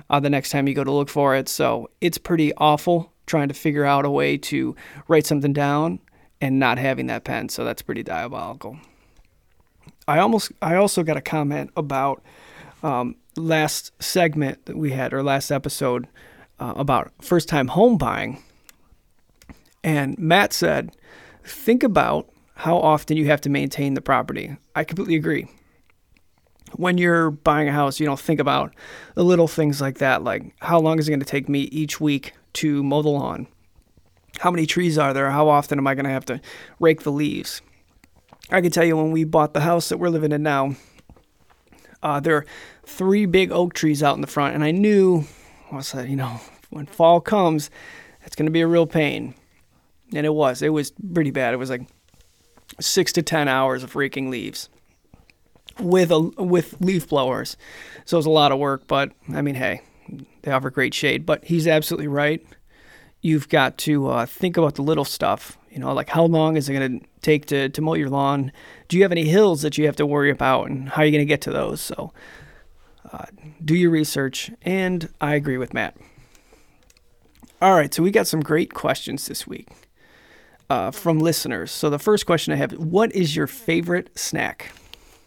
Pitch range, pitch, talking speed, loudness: 140-165 Hz, 150 Hz, 195 wpm, -21 LUFS